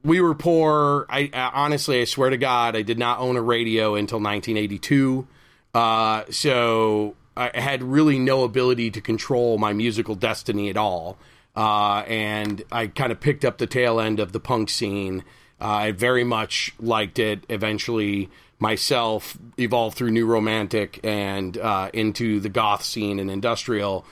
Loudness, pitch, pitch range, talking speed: -22 LUFS, 115 Hz, 105-125 Hz, 160 wpm